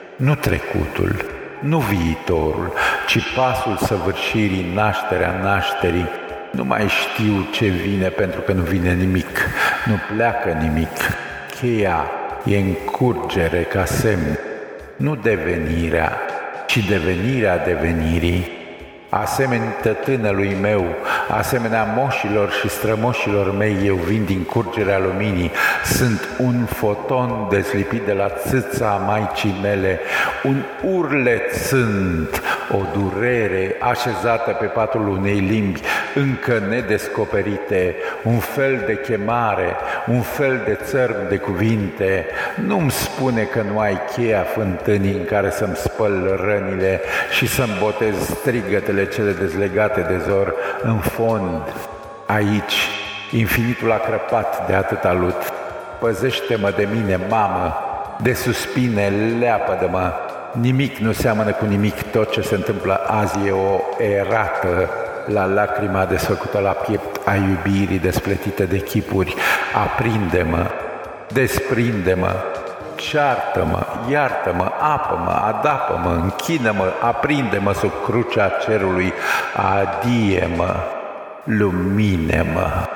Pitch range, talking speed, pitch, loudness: 95-110 Hz, 110 wpm, 100 Hz, -19 LUFS